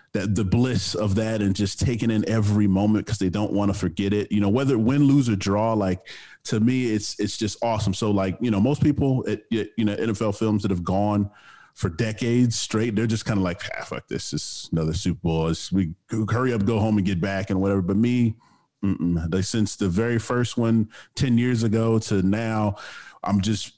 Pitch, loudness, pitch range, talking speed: 105 Hz, -23 LUFS, 100-115 Hz, 225 wpm